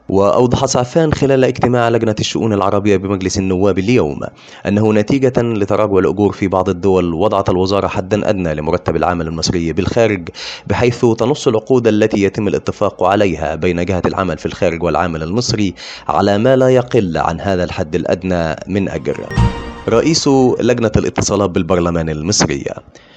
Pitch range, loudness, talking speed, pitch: 95-120 Hz, -15 LUFS, 140 wpm, 100 Hz